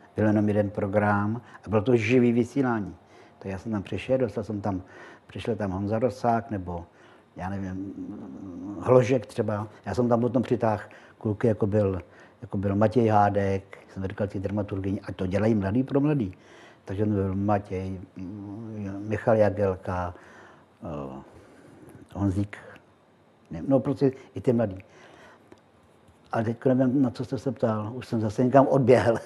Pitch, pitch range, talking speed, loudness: 105 Hz, 100-120 Hz, 150 wpm, -26 LUFS